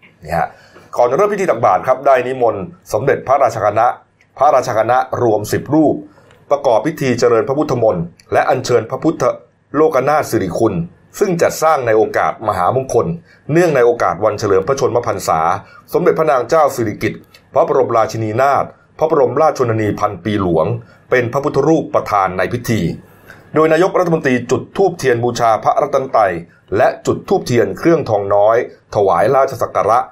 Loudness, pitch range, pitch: -15 LUFS, 105-160 Hz, 120 Hz